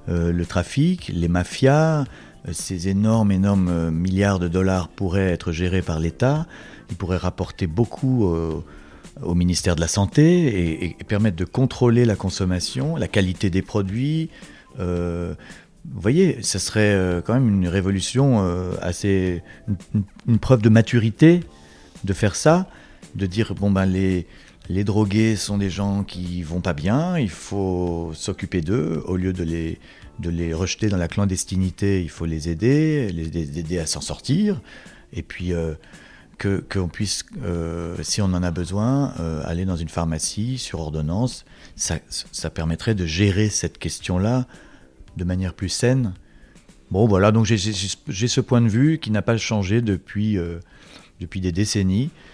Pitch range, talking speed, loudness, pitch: 85-110 Hz, 165 wpm, -22 LUFS, 95 Hz